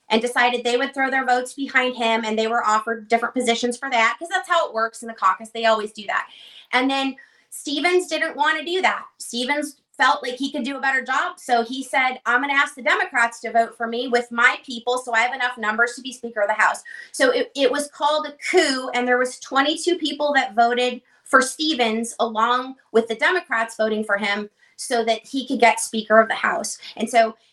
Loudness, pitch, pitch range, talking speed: -21 LUFS, 245 Hz, 230-275 Hz, 235 wpm